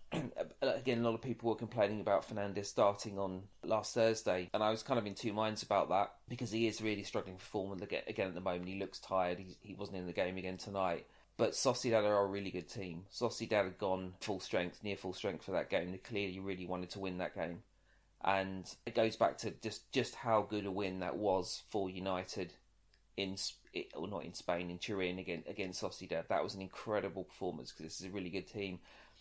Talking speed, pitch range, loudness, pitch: 220 wpm, 95-105 Hz, -39 LUFS, 95 Hz